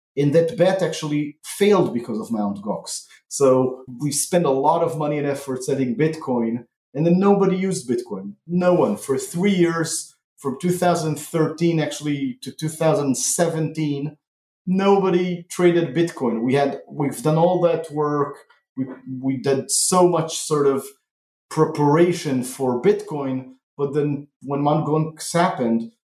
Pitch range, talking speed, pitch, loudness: 135-170 Hz, 140 wpm, 150 Hz, -21 LUFS